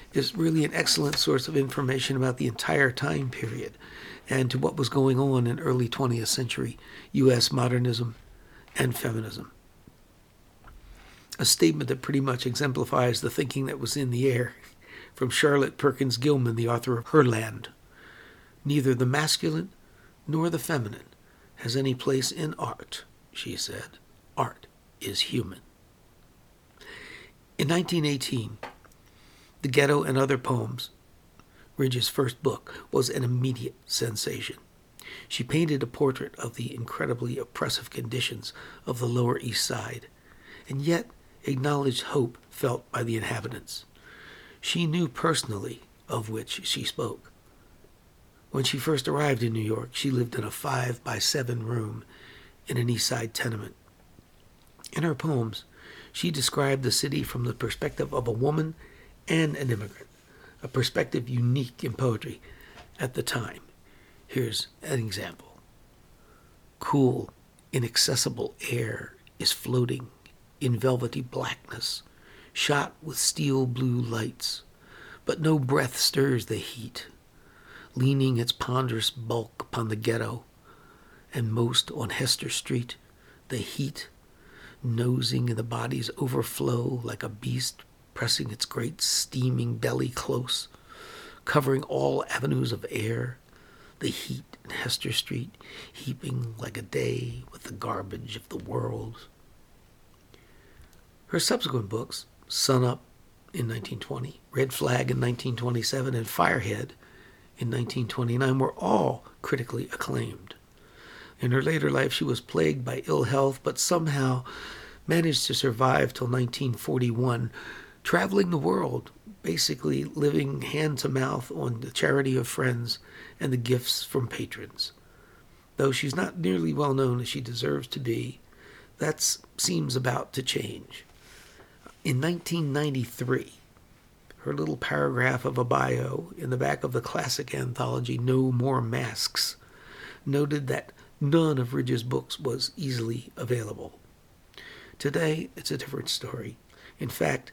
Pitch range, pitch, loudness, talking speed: 115-135 Hz, 125 Hz, -28 LUFS, 130 wpm